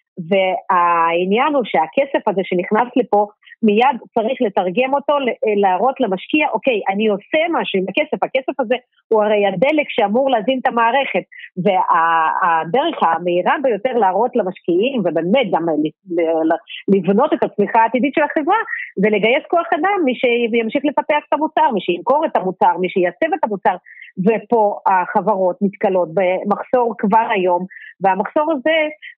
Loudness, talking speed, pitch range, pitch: -17 LUFS, 135 wpm, 185-275 Hz, 220 Hz